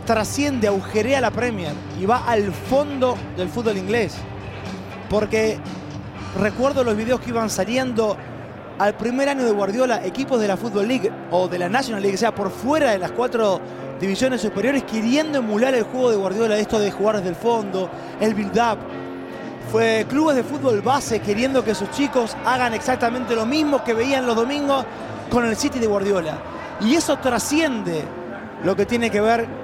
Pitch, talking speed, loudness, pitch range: 225 Hz, 175 wpm, -21 LUFS, 200-255 Hz